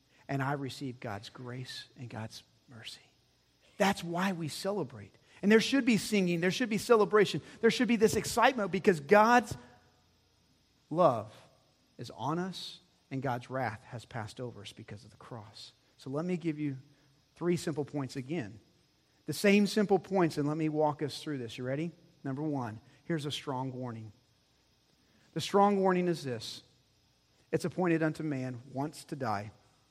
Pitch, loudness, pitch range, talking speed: 145 Hz, -31 LUFS, 125-180 Hz, 165 wpm